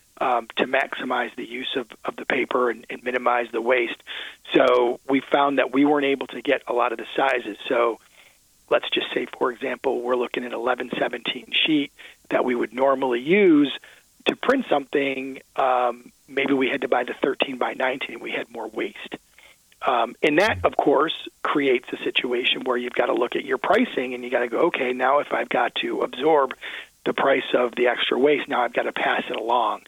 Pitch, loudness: 135 Hz, -23 LUFS